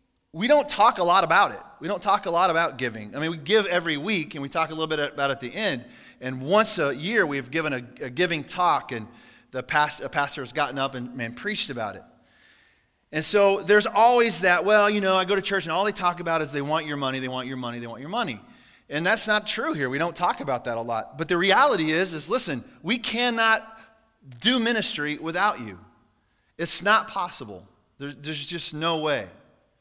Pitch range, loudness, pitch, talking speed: 135-205 Hz, -23 LUFS, 160 Hz, 235 wpm